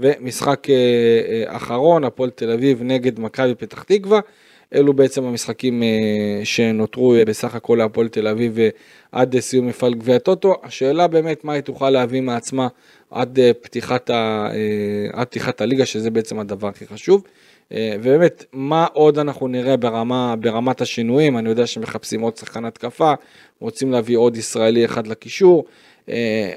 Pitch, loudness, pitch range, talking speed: 120 Hz, -18 LUFS, 115-135 Hz, 140 wpm